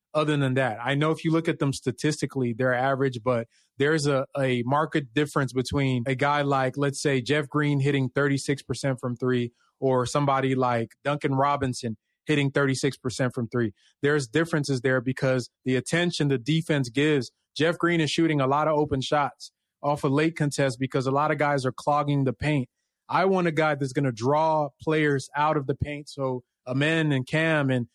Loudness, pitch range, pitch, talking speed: -25 LUFS, 130-150 Hz, 140 Hz, 195 wpm